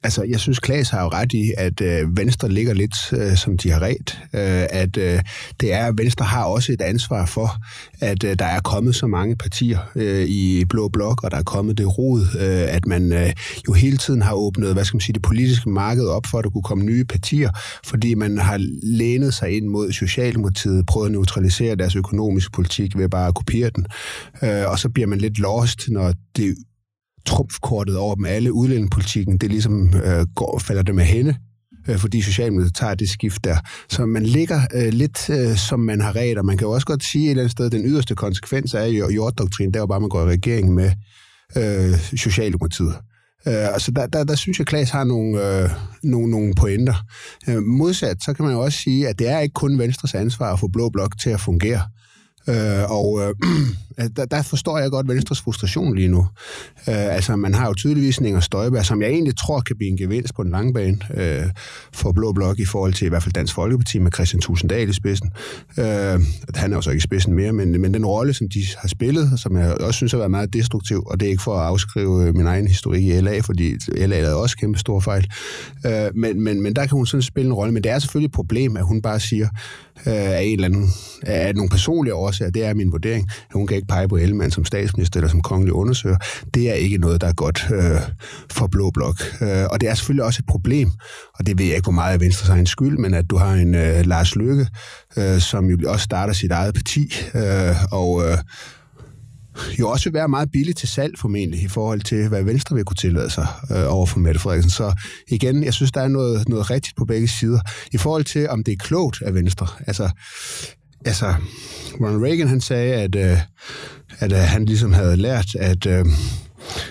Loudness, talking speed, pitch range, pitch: -20 LUFS, 225 wpm, 95-120 Hz, 105 Hz